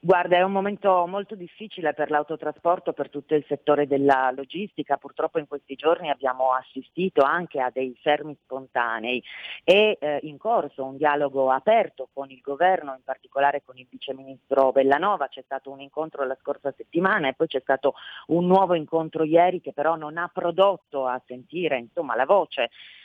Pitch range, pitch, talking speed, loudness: 135-170 Hz, 145 Hz, 170 wpm, -24 LUFS